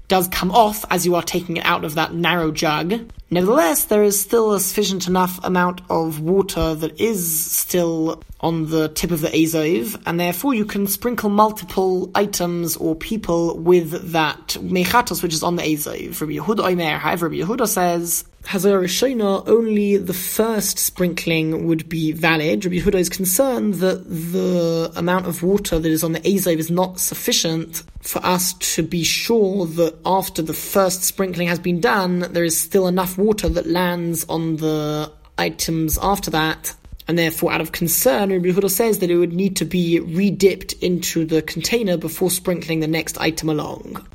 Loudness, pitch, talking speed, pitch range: -19 LUFS, 175 Hz, 170 wpm, 165-195 Hz